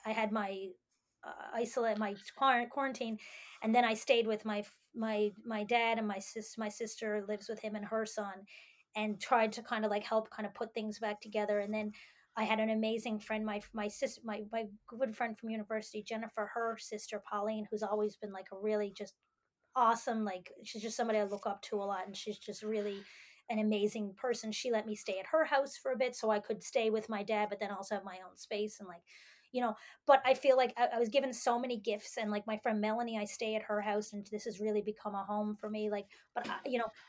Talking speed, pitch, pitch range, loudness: 240 wpm, 215 Hz, 210-230 Hz, -36 LUFS